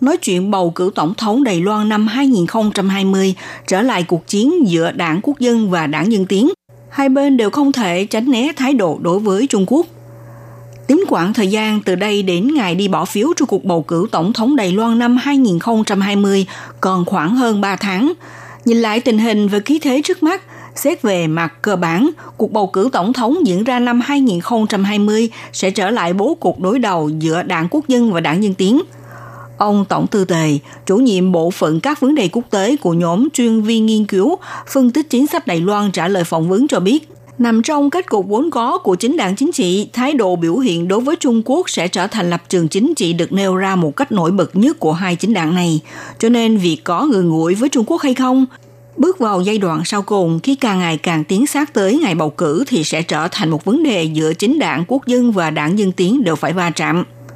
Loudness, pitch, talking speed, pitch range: -15 LUFS, 205 Hz, 225 wpm, 175-250 Hz